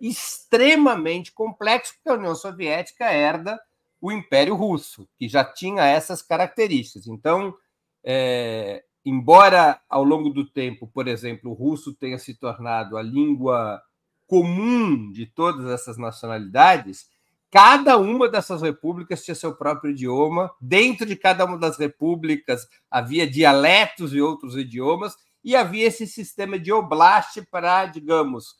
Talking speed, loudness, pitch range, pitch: 130 wpm, -19 LUFS, 135-200 Hz, 160 Hz